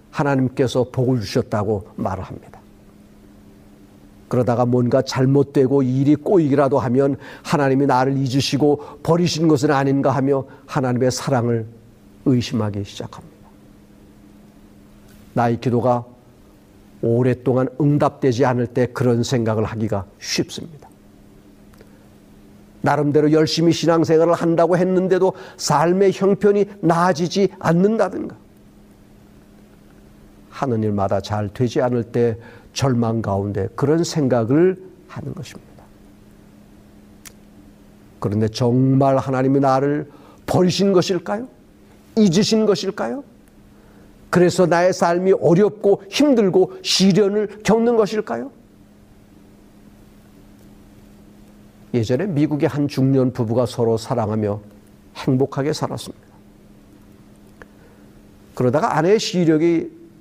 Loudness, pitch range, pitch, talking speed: -18 LUFS, 105-155 Hz, 125 Hz, 240 characters per minute